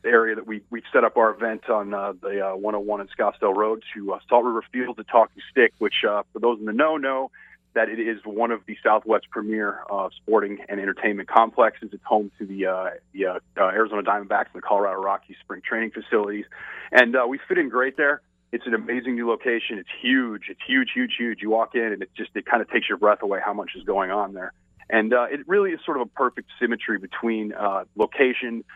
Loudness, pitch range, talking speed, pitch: -23 LUFS, 105-125 Hz, 230 wpm, 115 Hz